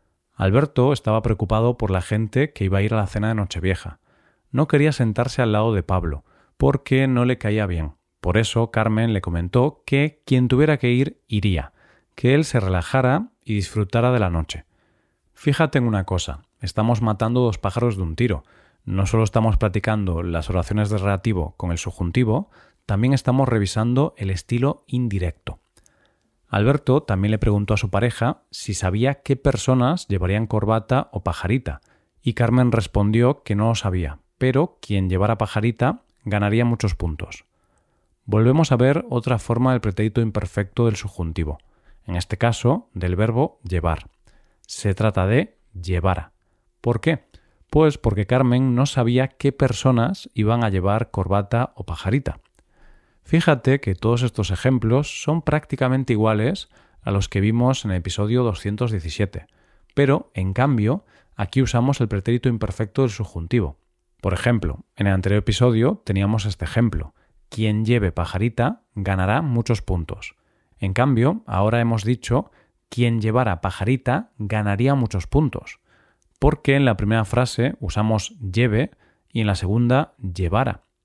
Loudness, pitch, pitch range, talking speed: -21 LUFS, 110 Hz, 100-125 Hz, 150 wpm